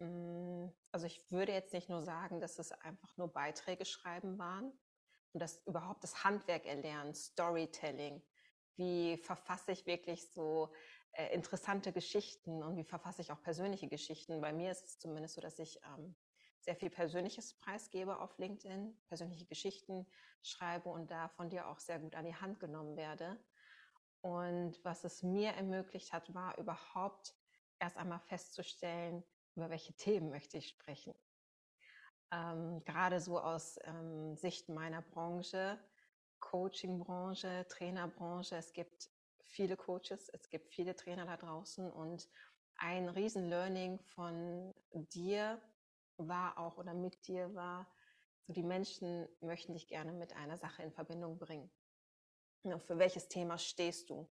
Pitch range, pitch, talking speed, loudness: 165-185 Hz, 175 Hz, 140 wpm, -44 LUFS